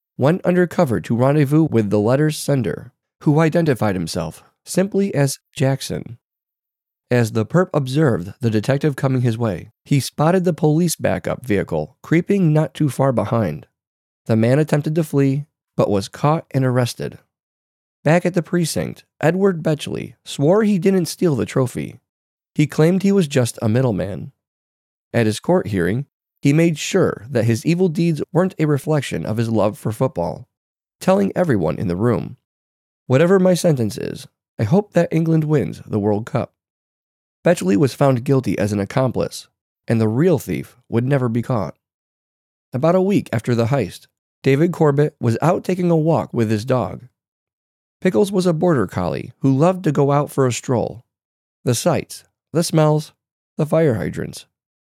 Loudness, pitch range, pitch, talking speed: -19 LUFS, 115-165 Hz, 140 Hz, 165 wpm